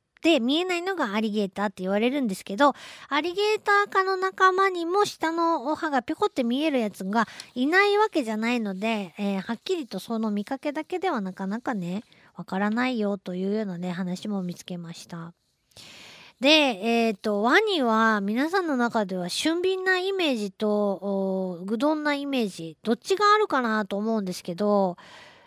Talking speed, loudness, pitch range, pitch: 355 characters per minute, -25 LUFS, 200-320 Hz, 230 Hz